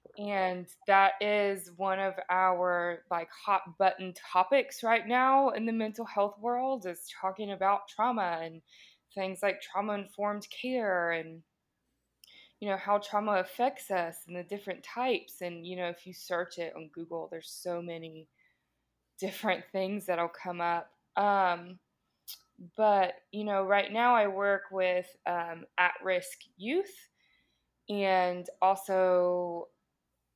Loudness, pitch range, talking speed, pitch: -31 LUFS, 175-205 Hz, 140 wpm, 190 Hz